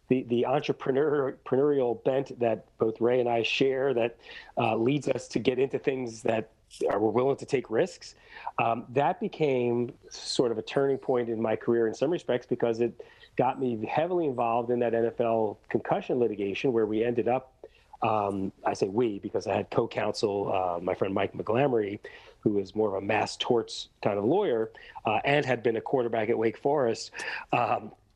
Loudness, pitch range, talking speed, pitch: -28 LUFS, 110-135 Hz, 185 wpm, 120 Hz